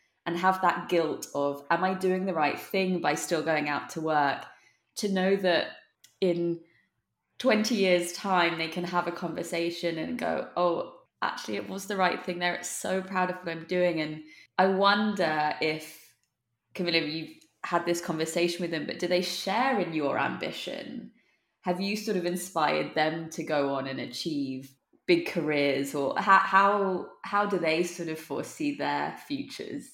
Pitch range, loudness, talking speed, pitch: 160-190 Hz, -28 LUFS, 175 wpm, 175 Hz